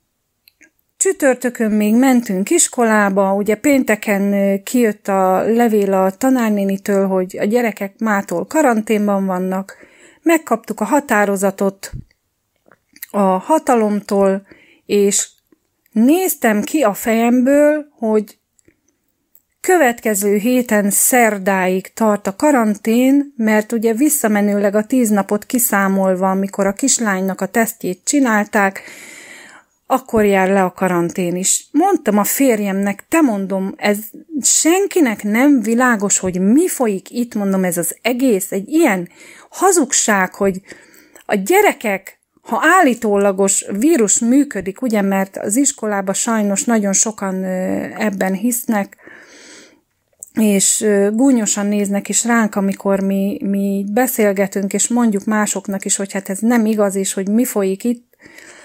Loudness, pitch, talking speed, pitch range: -15 LUFS, 210 Hz, 115 wpm, 195-245 Hz